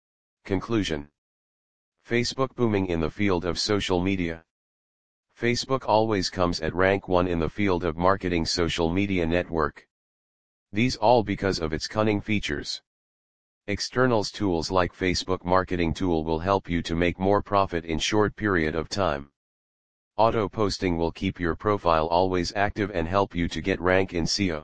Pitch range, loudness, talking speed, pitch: 85-100 Hz, -25 LUFS, 155 wpm, 90 Hz